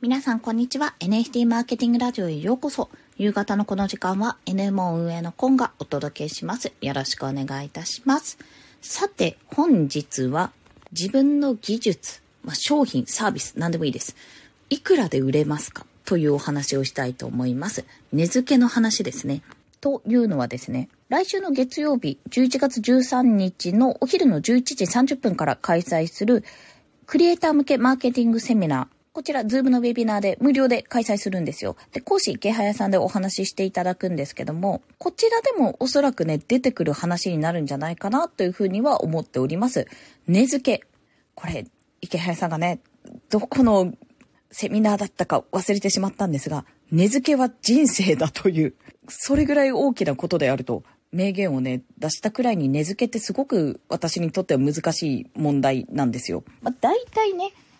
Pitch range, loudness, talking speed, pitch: 165-255 Hz, -23 LUFS, 360 characters per minute, 205 Hz